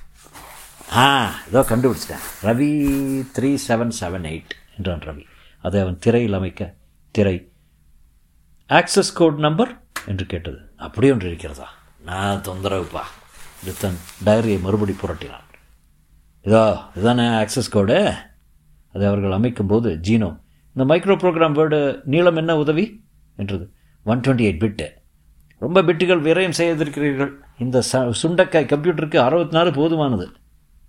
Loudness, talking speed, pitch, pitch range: -19 LUFS, 115 wpm, 110 Hz, 85-140 Hz